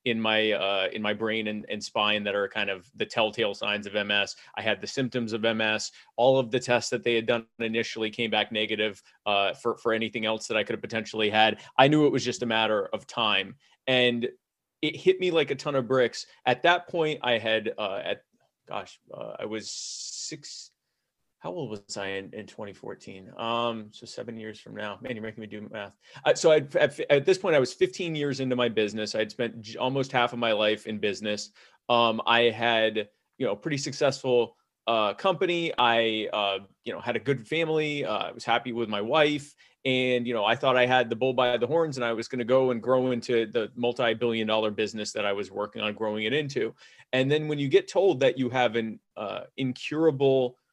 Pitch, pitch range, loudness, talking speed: 120 Hz, 110-130 Hz, -26 LUFS, 220 wpm